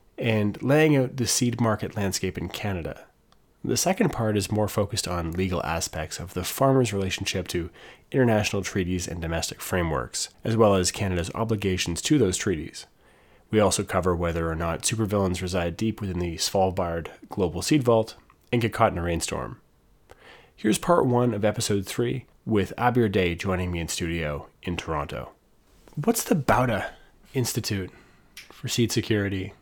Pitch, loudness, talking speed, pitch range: 100 Hz, -25 LUFS, 160 wpm, 85-115 Hz